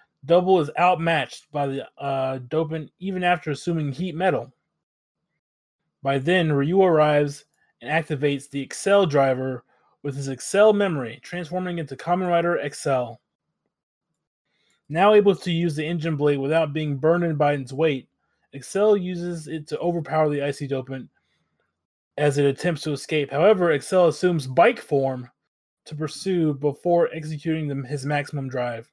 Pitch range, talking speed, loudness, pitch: 140-175 Hz, 145 wpm, -23 LUFS, 155 Hz